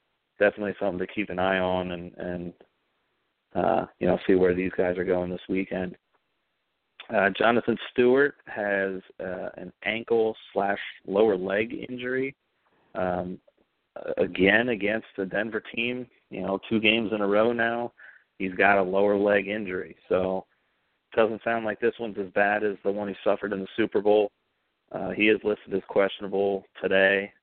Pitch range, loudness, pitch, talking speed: 95-110 Hz, -26 LUFS, 100 Hz, 165 wpm